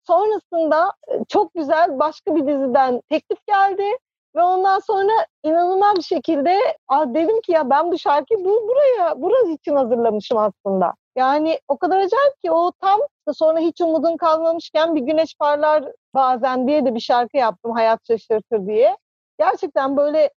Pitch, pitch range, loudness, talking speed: 315 Hz, 275-360 Hz, -18 LUFS, 155 wpm